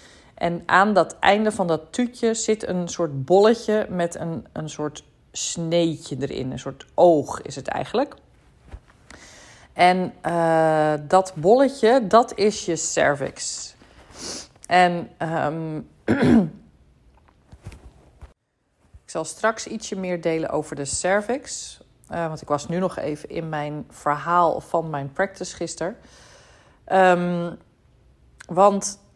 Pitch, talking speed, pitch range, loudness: 170 Hz, 120 wpm, 155-190 Hz, -22 LUFS